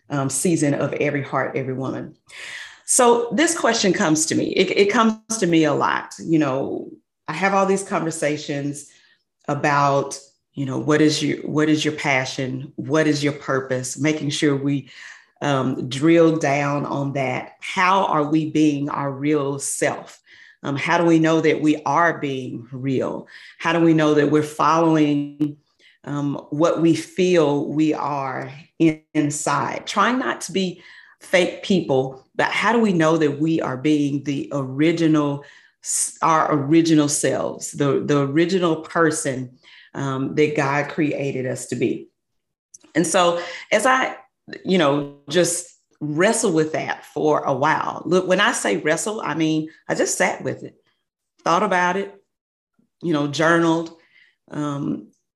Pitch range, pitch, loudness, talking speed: 145-165 Hz, 150 Hz, -20 LUFS, 155 wpm